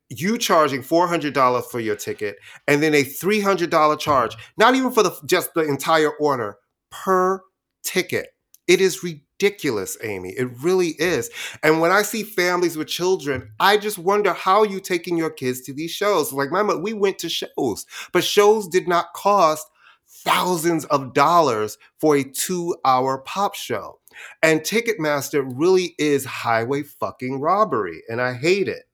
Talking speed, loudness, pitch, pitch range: 160 wpm, -20 LUFS, 170 Hz, 140-195 Hz